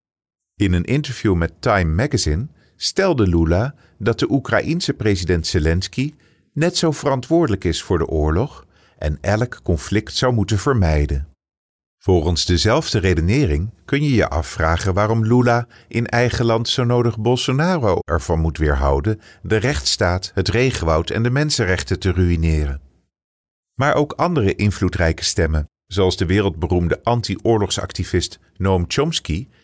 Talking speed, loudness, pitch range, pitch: 130 wpm, -19 LUFS, 85-120 Hz, 100 Hz